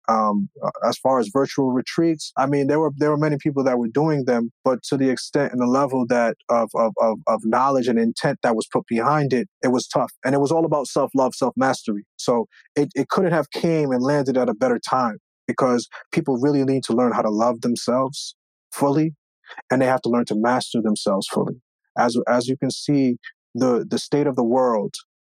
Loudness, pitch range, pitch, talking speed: -21 LUFS, 120-145 Hz, 130 Hz, 215 wpm